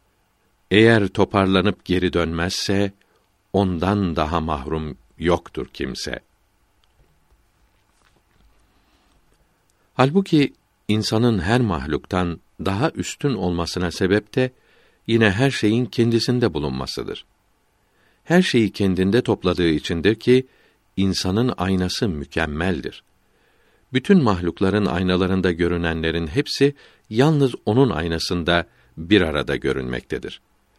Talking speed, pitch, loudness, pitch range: 85 wpm, 95 Hz, -20 LUFS, 85-115 Hz